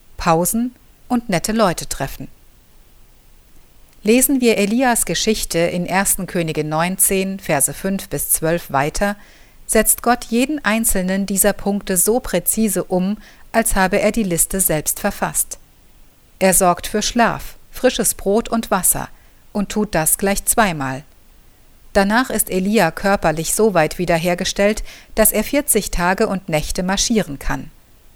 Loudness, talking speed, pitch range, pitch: -17 LUFS, 130 wpm, 175-220 Hz, 200 Hz